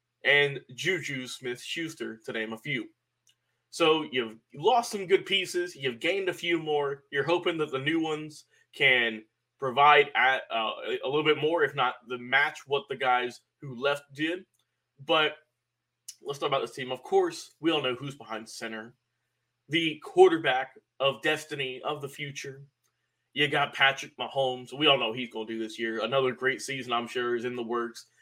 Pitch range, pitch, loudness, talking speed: 125-155 Hz, 135 Hz, -27 LUFS, 185 wpm